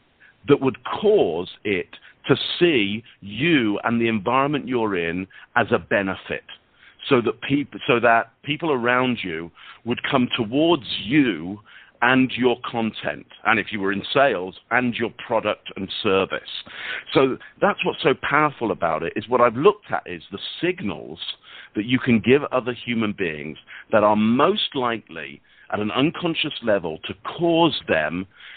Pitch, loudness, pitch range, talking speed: 120 Hz, -22 LUFS, 105-140 Hz, 165 wpm